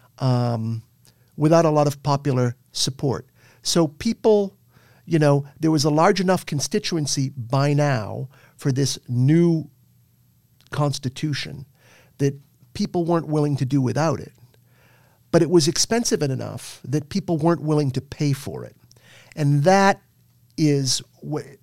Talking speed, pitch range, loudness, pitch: 135 wpm, 125-155 Hz, -21 LUFS, 140 Hz